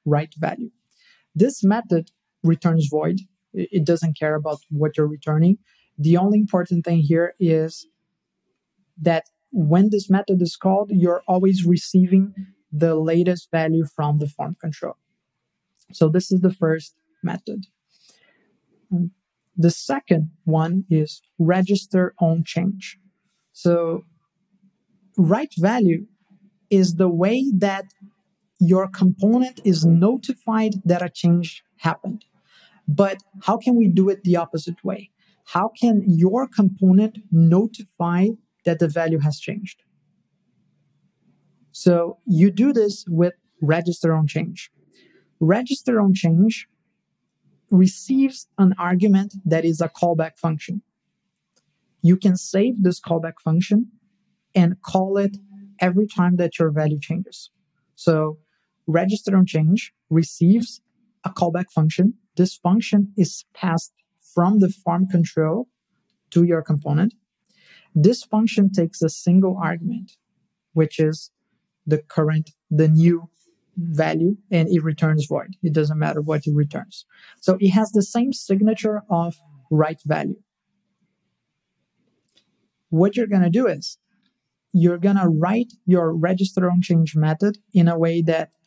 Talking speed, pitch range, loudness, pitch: 125 wpm, 165-200 Hz, -20 LUFS, 180 Hz